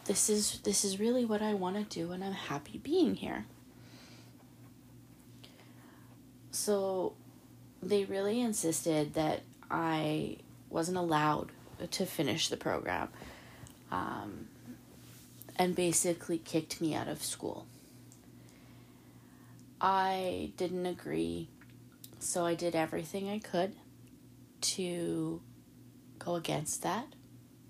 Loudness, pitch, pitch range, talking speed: -34 LUFS, 170 Hz, 125-195 Hz, 105 wpm